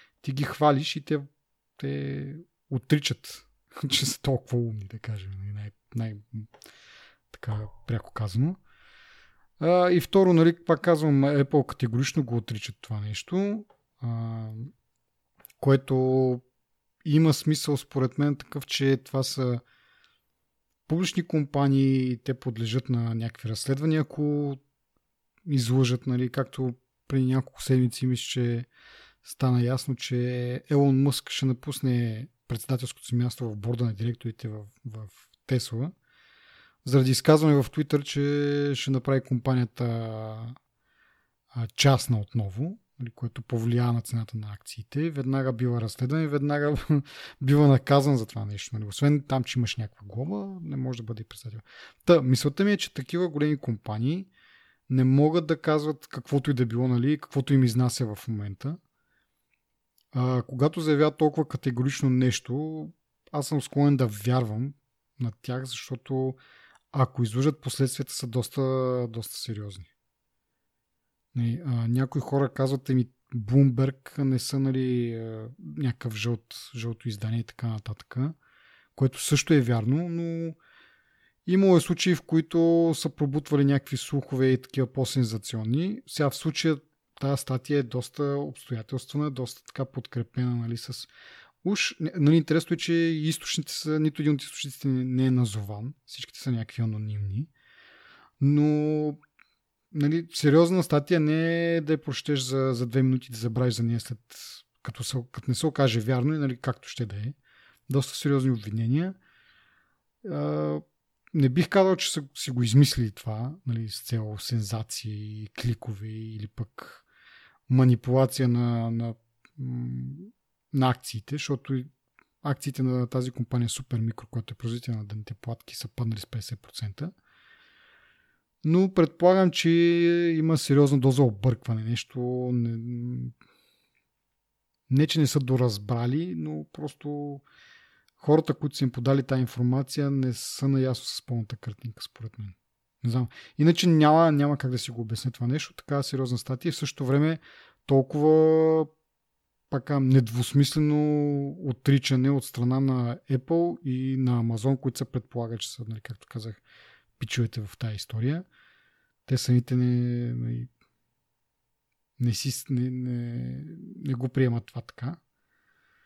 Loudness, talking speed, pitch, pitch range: -27 LUFS, 135 wpm, 130 Hz, 120-145 Hz